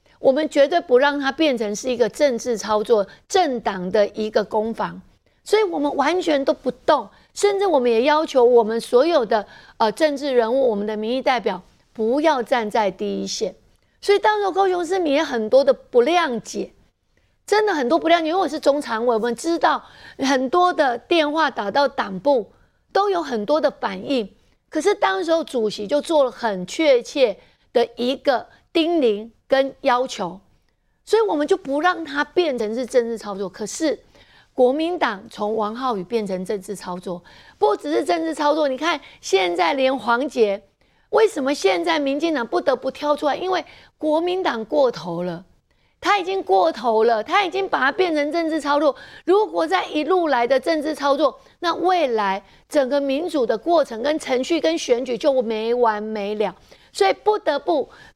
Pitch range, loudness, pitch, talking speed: 230-330 Hz, -20 LUFS, 275 Hz, 260 characters per minute